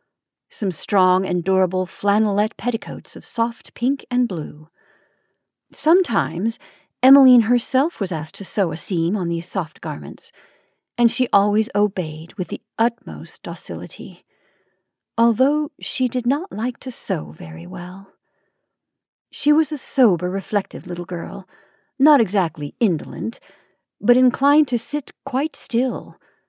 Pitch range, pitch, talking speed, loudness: 185-255 Hz, 215 Hz, 130 wpm, -20 LUFS